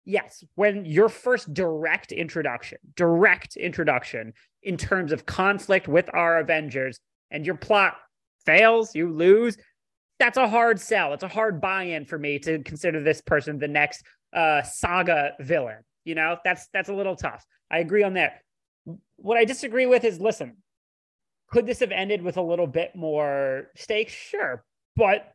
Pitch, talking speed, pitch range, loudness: 175 Hz, 165 wpm, 155-210 Hz, -23 LUFS